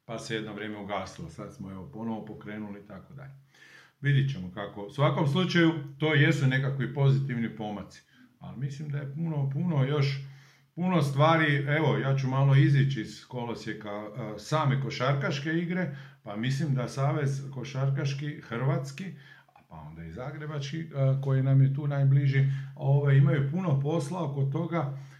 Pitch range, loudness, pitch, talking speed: 125-150 Hz, -28 LUFS, 135 Hz, 150 wpm